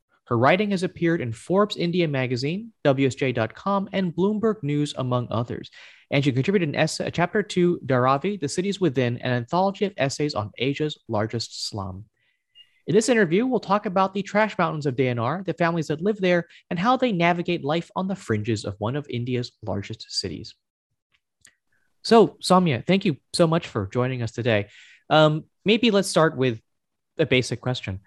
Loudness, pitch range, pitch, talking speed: -23 LUFS, 125-190 Hz, 160 Hz, 175 wpm